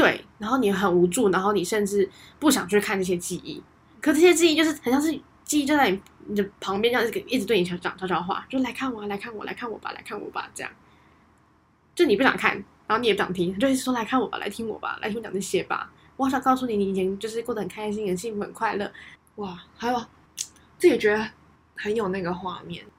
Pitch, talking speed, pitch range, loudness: 215 Hz, 345 characters per minute, 195-255 Hz, -25 LUFS